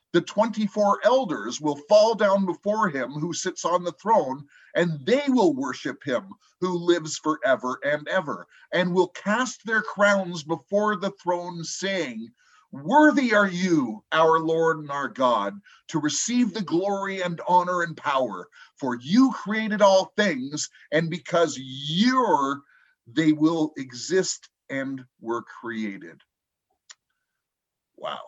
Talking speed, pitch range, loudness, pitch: 135 wpm, 155-210 Hz, -24 LUFS, 180 Hz